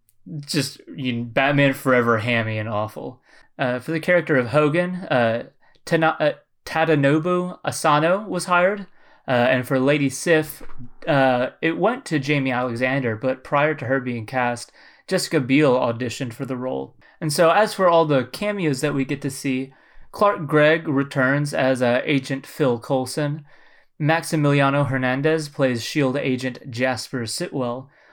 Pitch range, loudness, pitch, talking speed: 130-155 Hz, -21 LUFS, 140 Hz, 150 wpm